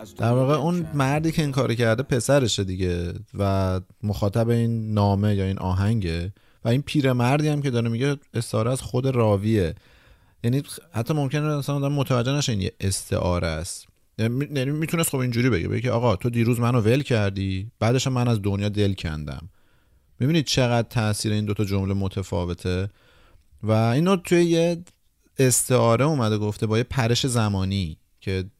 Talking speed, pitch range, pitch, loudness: 160 wpm, 100-130 Hz, 115 Hz, -23 LUFS